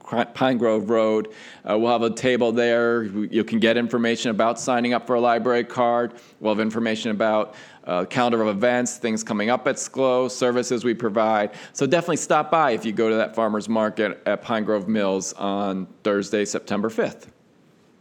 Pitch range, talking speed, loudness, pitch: 110-120 Hz, 185 wpm, -22 LUFS, 115 Hz